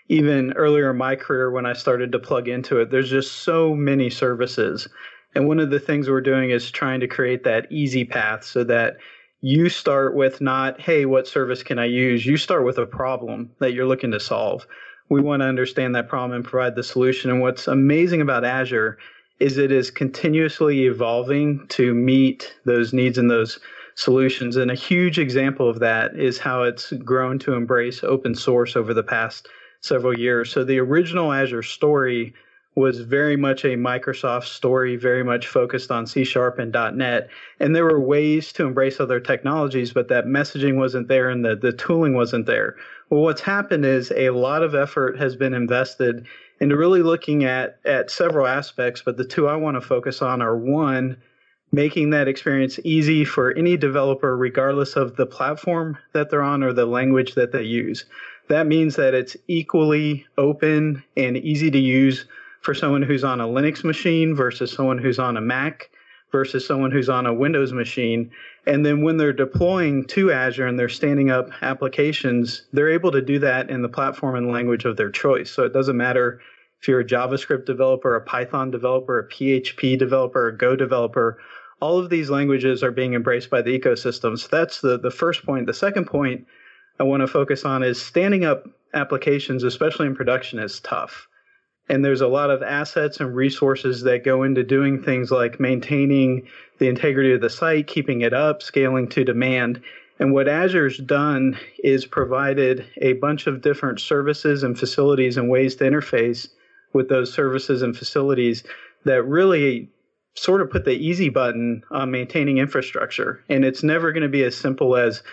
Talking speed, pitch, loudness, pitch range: 185 wpm, 135 Hz, -20 LUFS, 125-145 Hz